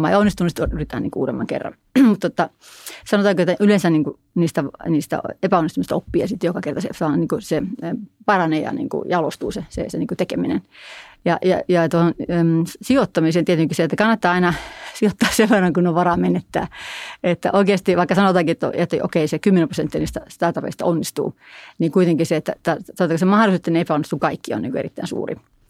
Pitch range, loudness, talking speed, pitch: 165-195 Hz, -19 LUFS, 190 wpm, 175 Hz